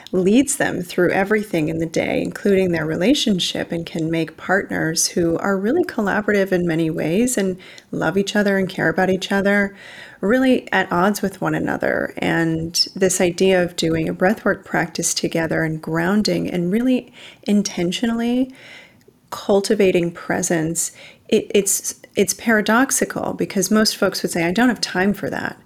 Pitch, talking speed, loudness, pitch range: 190 Hz, 155 wpm, -19 LUFS, 170-215 Hz